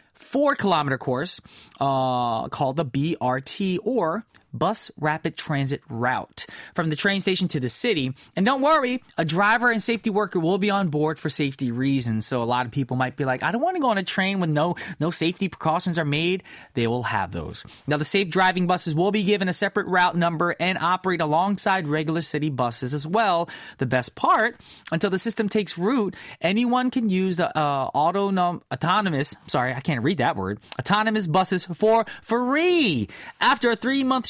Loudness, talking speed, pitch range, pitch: -23 LUFS, 190 wpm, 145-205 Hz, 175 Hz